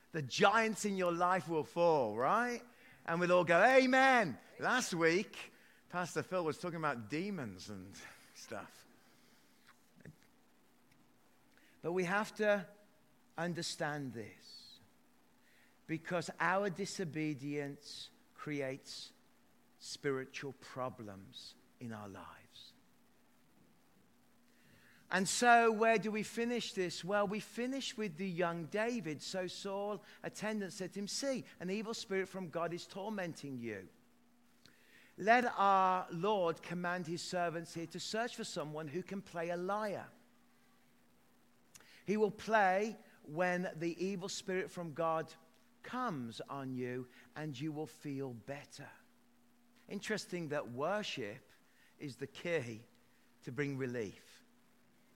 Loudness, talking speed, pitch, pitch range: -37 LUFS, 120 wpm, 180 Hz, 150-205 Hz